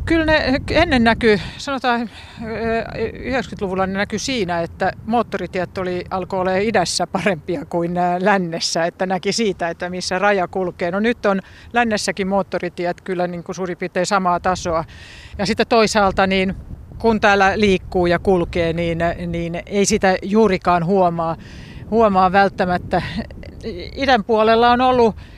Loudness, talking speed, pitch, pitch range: -18 LUFS, 135 wpm, 195 Hz, 180-220 Hz